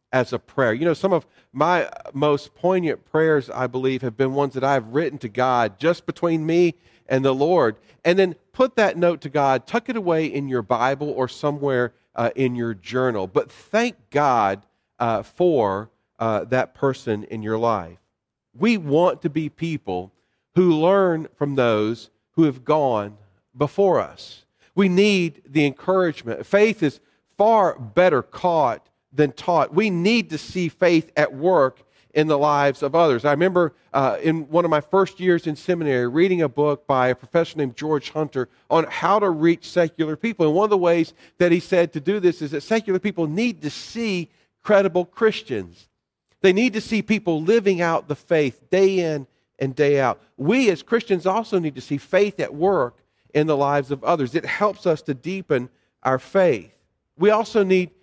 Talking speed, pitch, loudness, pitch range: 185 wpm, 155 Hz, -21 LUFS, 130-185 Hz